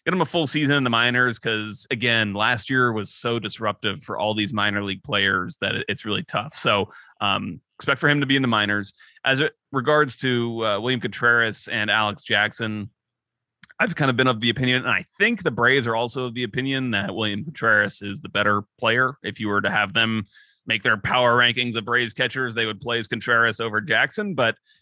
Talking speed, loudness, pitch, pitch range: 215 wpm, -22 LUFS, 120 Hz, 105-130 Hz